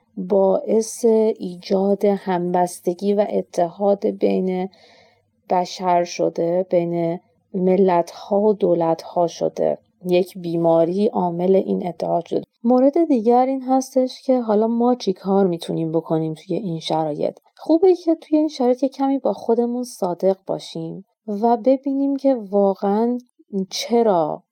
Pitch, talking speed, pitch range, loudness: 200 Hz, 125 wpm, 180-240 Hz, -20 LUFS